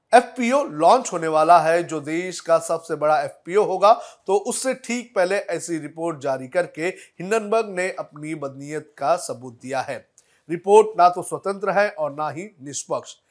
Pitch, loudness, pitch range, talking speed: 175 Hz, -21 LUFS, 155-205 Hz, 165 wpm